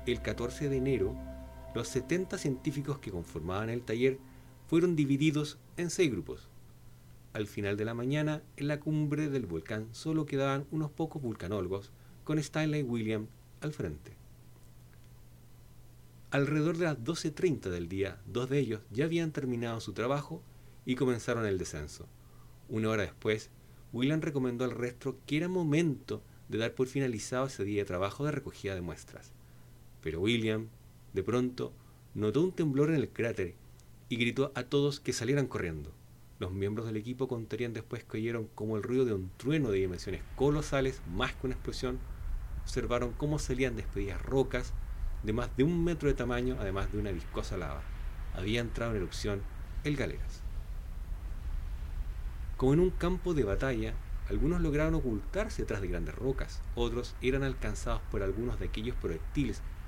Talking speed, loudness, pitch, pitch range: 160 wpm, -34 LUFS, 120 Hz, 95-140 Hz